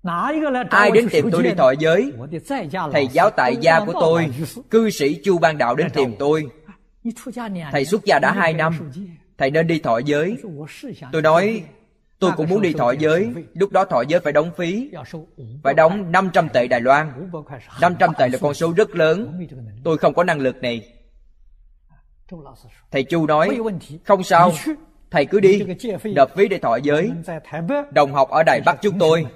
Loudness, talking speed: -18 LUFS, 175 wpm